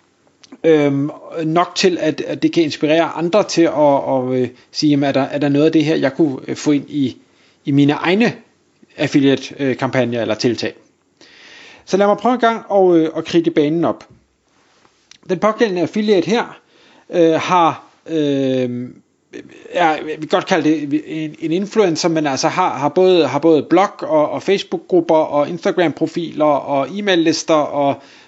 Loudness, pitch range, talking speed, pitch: -16 LUFS, 145-175 Hz, 165 wpm, 155 Hz